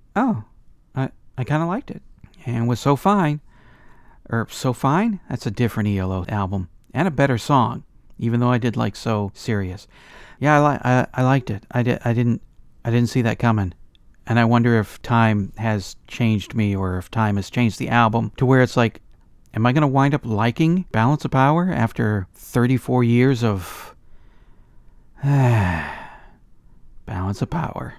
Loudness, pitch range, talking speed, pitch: -20 LUFS, 105-130 Hz, 175 wpm, 120 Hz